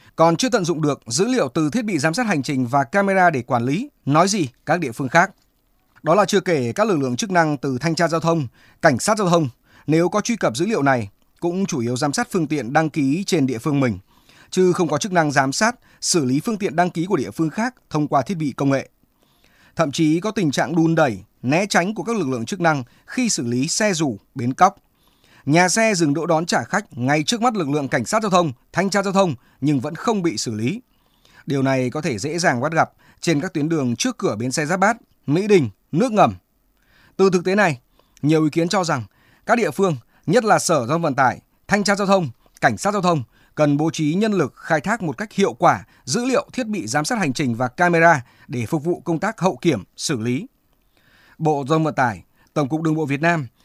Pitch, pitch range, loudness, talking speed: 160 Hz, 140-190 Hz, -20 LUFS, 250 wpm